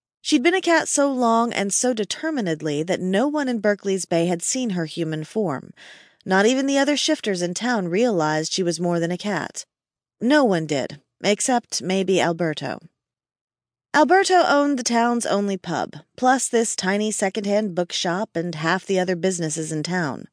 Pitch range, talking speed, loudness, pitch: 175-245 Hz, 170 wpm, -21 LUFS, 200 Hz